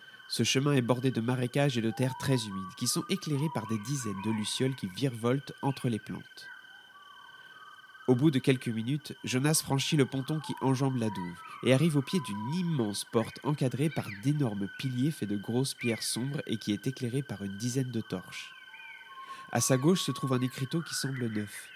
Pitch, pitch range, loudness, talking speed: 135 Hz, 120-155 Hz, -31 LUFS, 200 wpm